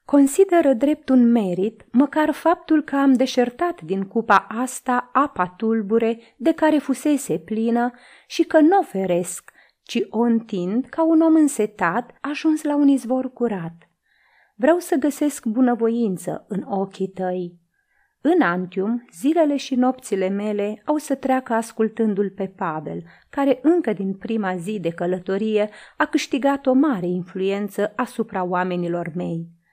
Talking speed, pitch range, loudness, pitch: 140 wpm, 195-285 Hz, -21 LUFS, 235 Hz